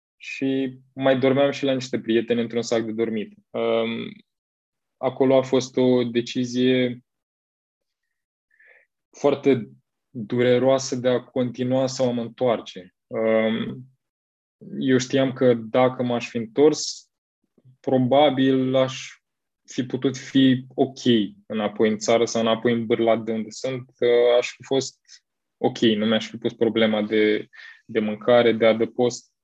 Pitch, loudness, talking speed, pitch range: 125 Hz, -22 LUFS, 125 wpm, 115-130 Hz